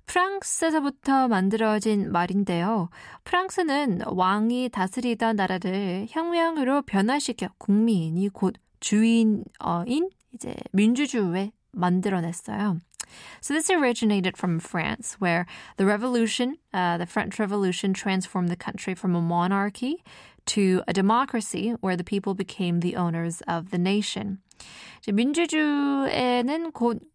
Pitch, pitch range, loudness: 205 Hz, 185-250 Hz, -25 LUFS